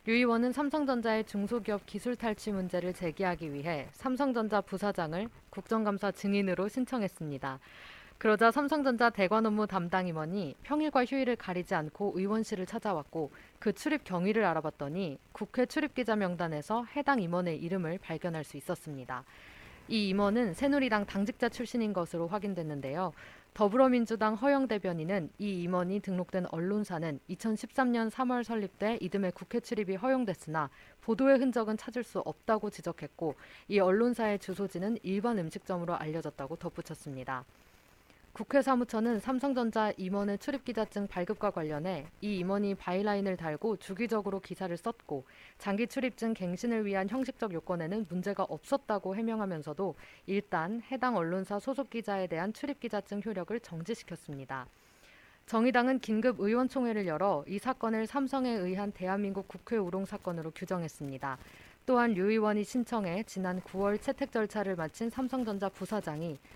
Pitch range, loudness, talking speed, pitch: 180-230 Hz, -33 LUFS, 360 characters per minute, 200 Hz